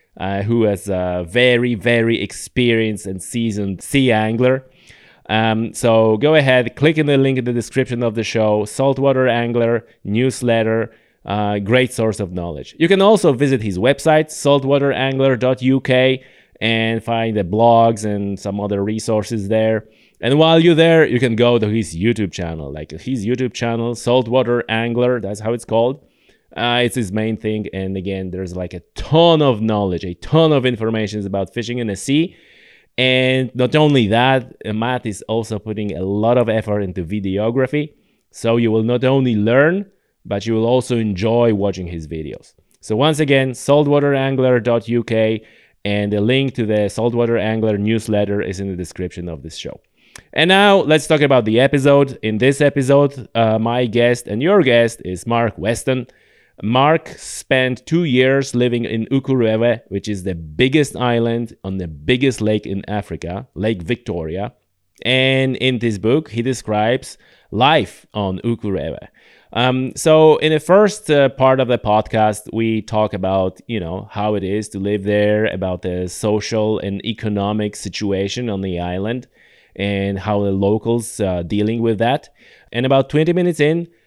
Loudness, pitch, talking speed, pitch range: -17 LUFS, 115 Hz, 165 wpm, 105-130 Hz